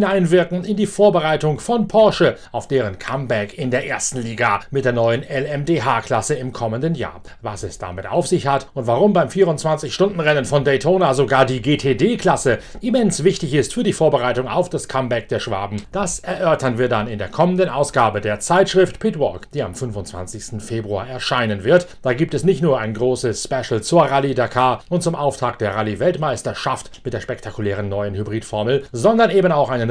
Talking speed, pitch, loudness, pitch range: 180 wpm, 135 Hz, -18 LUFS, 115-170 Hz